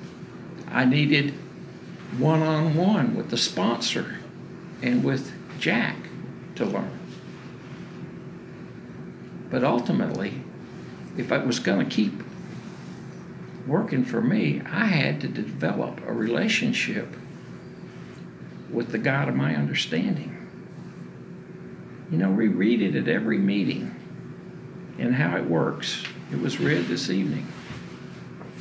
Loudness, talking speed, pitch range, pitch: -25 LUFS, 105 wpm, 120-160 Hz, 145 Hz